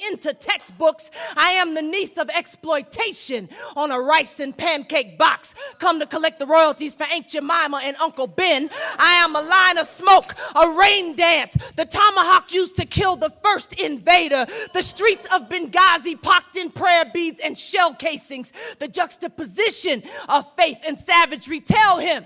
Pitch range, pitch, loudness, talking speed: 300-365 Hz, 330 Hz, -18 LUFS, 165 wpm